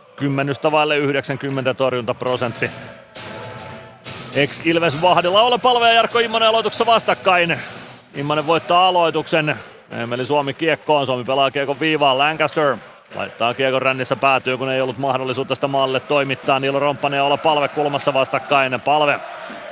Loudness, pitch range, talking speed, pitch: -18 LUFS, 130-155 Hz, 130 wpm, 140 Hz